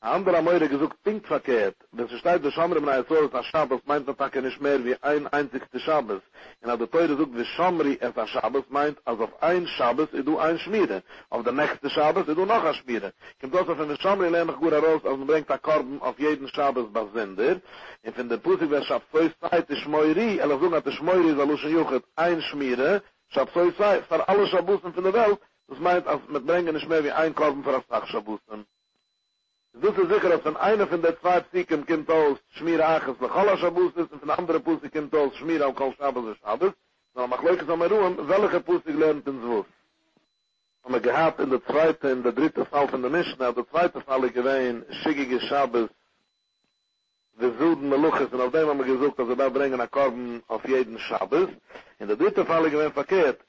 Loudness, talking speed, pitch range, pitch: -24 LUFS, 195 wpm, 135-170 Hz, 155 Hz